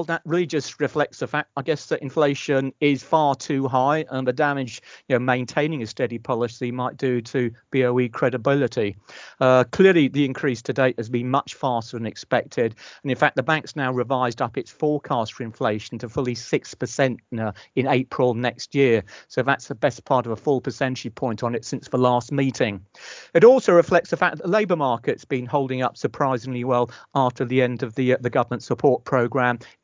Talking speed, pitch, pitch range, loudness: 205 wpm, 130 Hz, 125-145 Hz, -22 LUFS